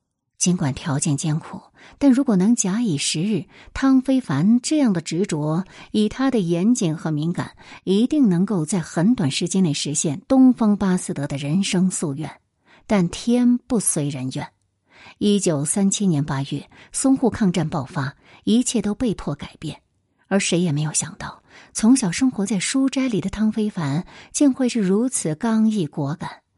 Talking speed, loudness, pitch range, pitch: 240 characters per minute, -21 LUFS, 155-230 Hz, 190 Hz